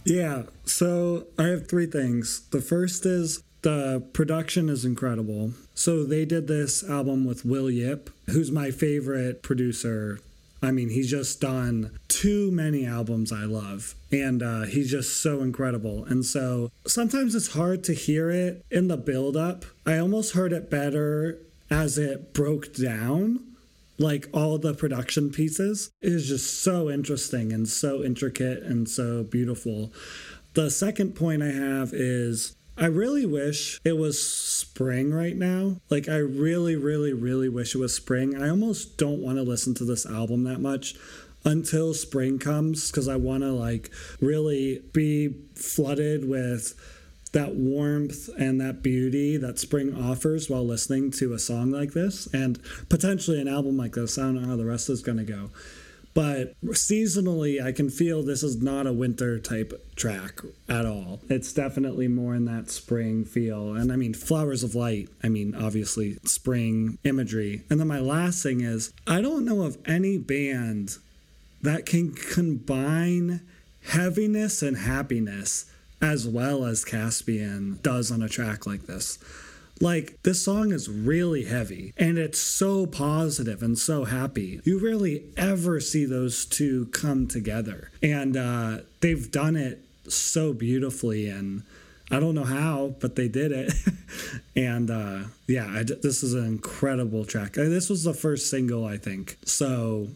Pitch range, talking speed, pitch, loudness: 120-155 Hz, 160 wpm, 135 Hz, -26 LUFS